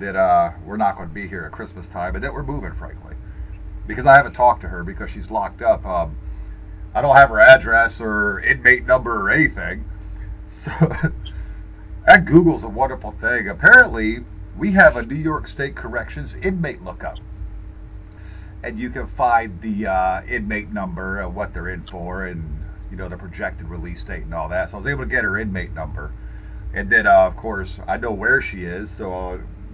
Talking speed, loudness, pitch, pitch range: 195 wpm, -17 LUFS, 100 Hz, 90-115 Hz